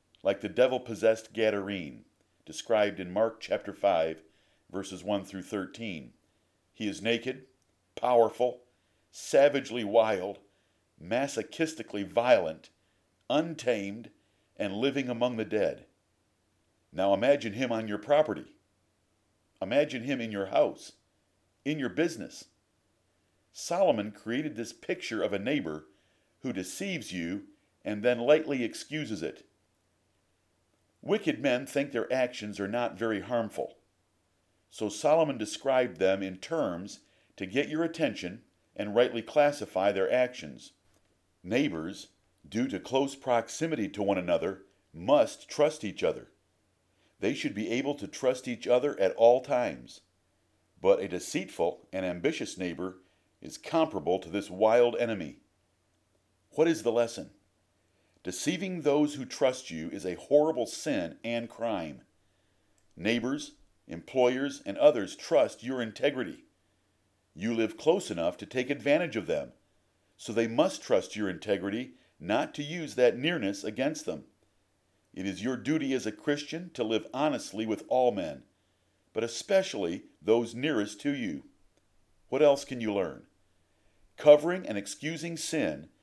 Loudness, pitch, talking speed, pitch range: -30 LUFS, 115 Hz, 130 wpm, 100-135 Hz